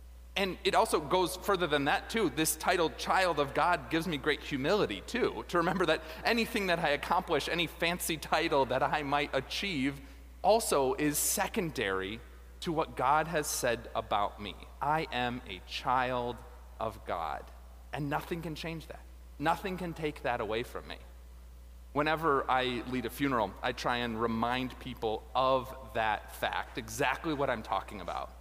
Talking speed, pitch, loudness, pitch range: 165 wpm, 135 Hz, -32 LUFS, 110-160 Hz